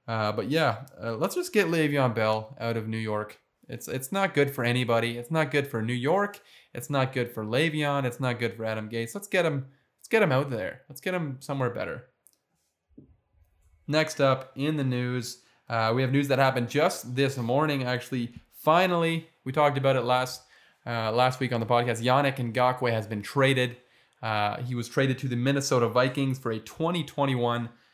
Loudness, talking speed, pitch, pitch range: -27 LUFS, 200 wpm, 125 Hz, 115-140 Hz